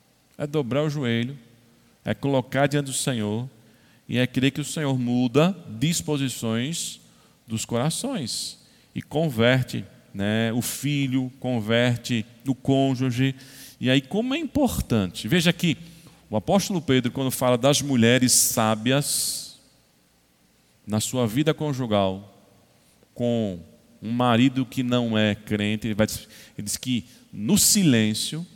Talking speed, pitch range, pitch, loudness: 125 wpm, 115-145 Hz, 125 Hz, -23 LUFS